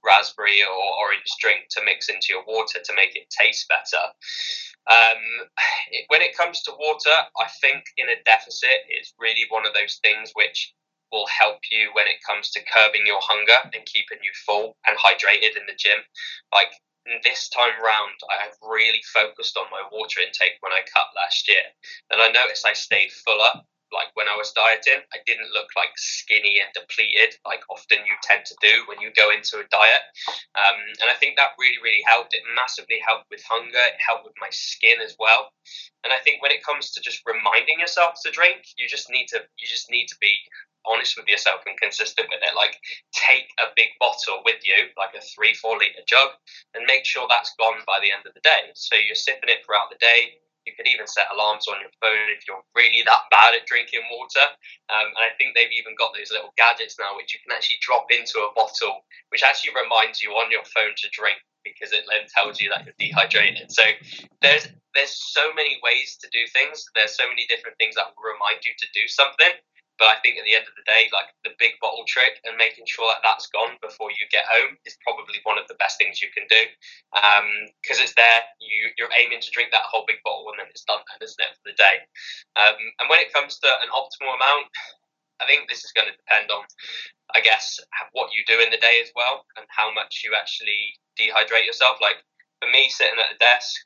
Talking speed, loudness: 220 wpm, -19 LUFS